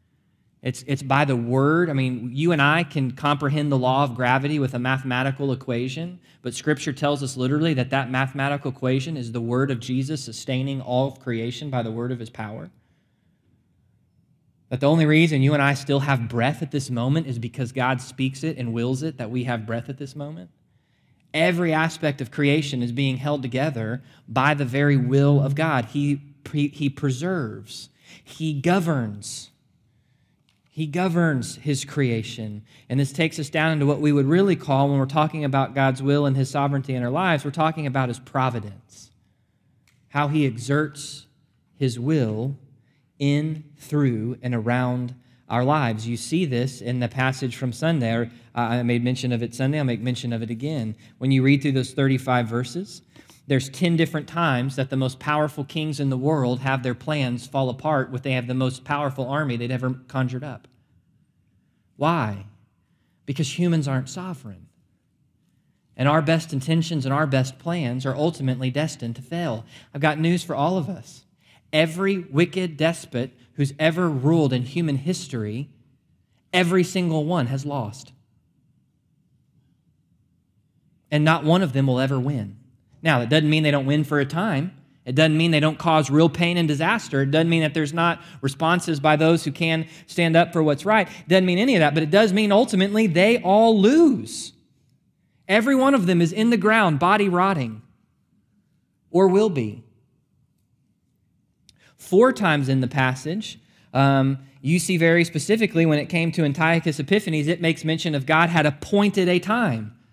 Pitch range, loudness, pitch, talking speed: 130-160 Hz, -22 LUFS, 140 Hz, 180 wpm